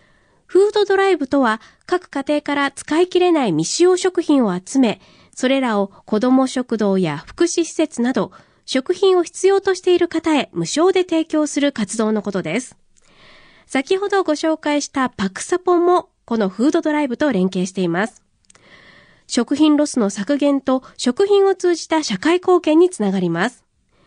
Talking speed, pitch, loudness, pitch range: 315 characters per minute, 290 Hz, -18 LUFS, 225-345 Hz